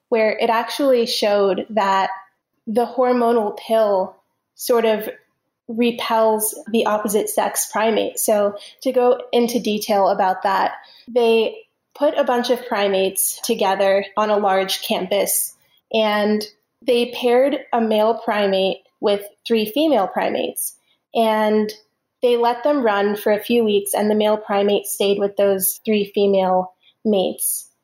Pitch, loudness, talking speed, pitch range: 215 Hz, -19 LUFS, 135 wpm, 200-235 Hz